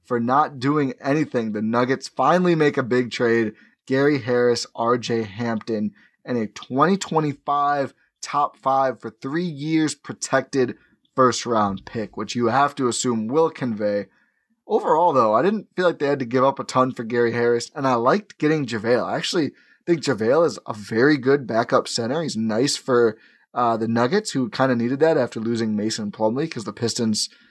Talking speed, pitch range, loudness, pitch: 180 wpm, 115-145 Hz, -22 LUFS, 125 Hz